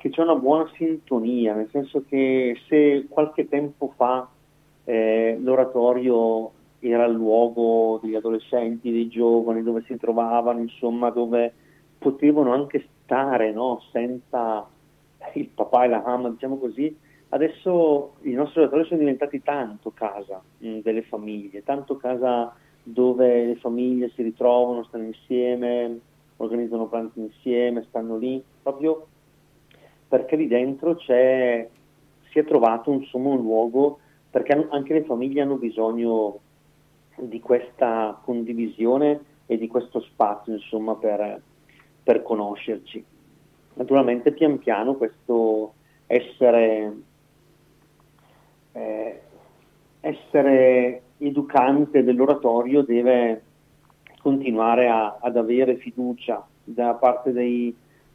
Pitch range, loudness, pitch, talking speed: 115-140 Hz, -22 LUFS, 125 Hz, 110 wpm